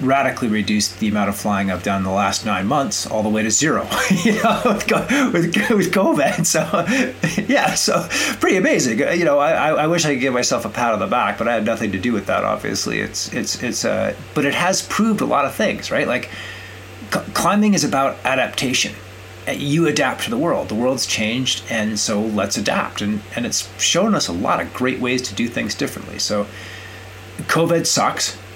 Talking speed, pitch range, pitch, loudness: 205 wpm, 105-170 Hz, 130 Hz, -18 LUFS